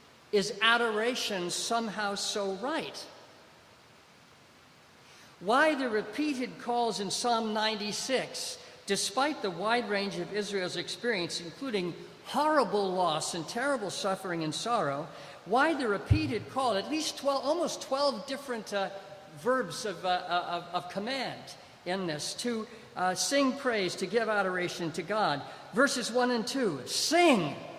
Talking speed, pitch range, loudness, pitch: 130 wpm, 185-250 Hz, -30 LUFS, 210 Hz